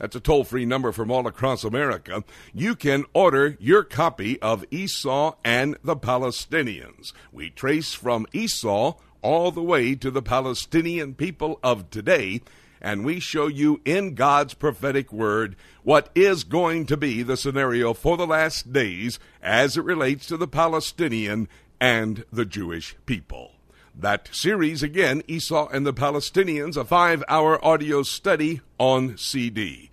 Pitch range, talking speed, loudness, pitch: 125-160 Hz, 150 wpm, -23 LUFS, 140 Hz